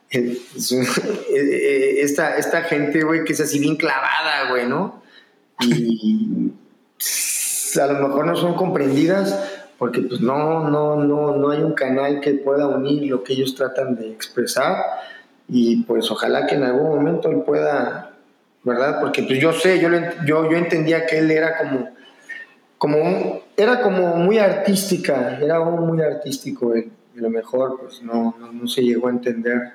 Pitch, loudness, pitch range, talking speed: 145 Hz, -19 LUFS, 125-165 Hz, 160 wpm